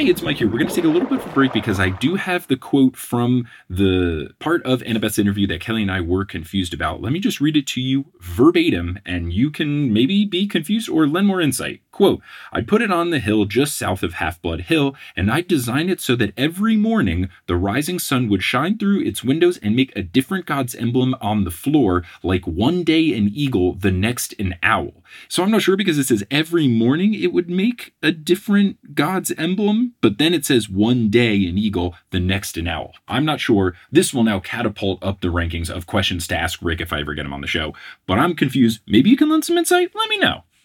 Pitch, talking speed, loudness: 125 Hz, 240 wpm, -19 LUFS